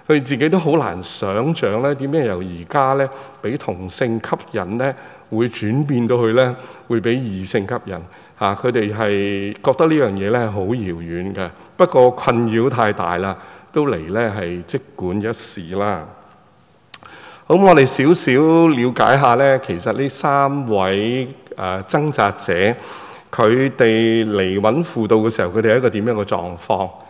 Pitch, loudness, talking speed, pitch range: 115 Hz, -17 LUFS, 225 characters per minute, 100-135 Hz